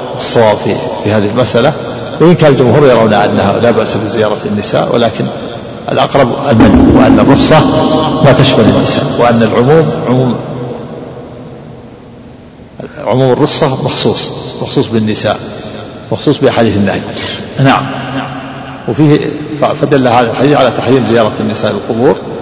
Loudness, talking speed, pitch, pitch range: -9 LUFS, 120 wpm, 125 Hz, 110-150 Hz